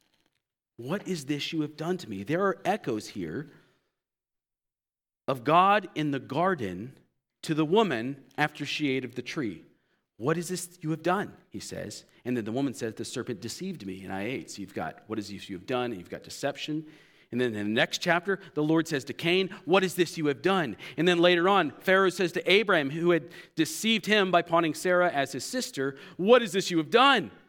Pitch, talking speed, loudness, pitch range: 160 Hz, 220 wpm, -27 LUFS, 135-185 Hz